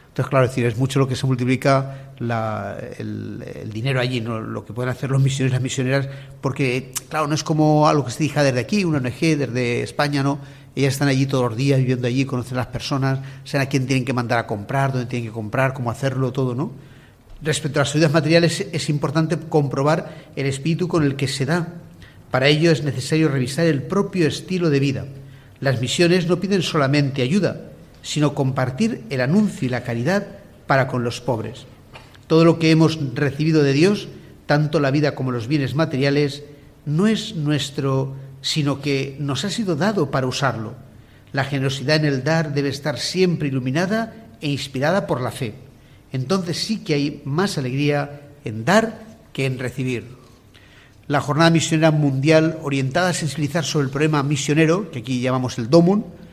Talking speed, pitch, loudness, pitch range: 190 wpm, 140 Hz, -20 LUFS, 130-155 Hz